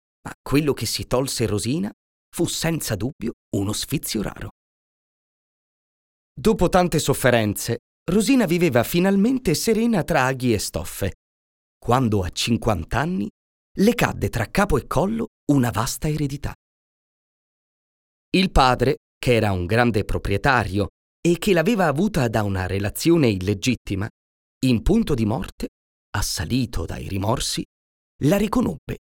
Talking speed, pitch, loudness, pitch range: 120 wpm, 120 Hz, -22 LUFS, 100-165 Hz